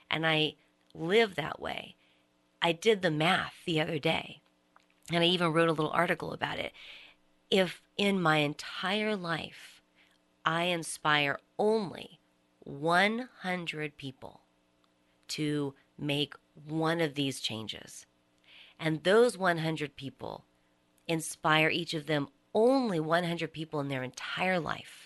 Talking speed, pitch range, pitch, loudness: 125 wpm, 125-170 Hz, 155 Hz, -30 LUFS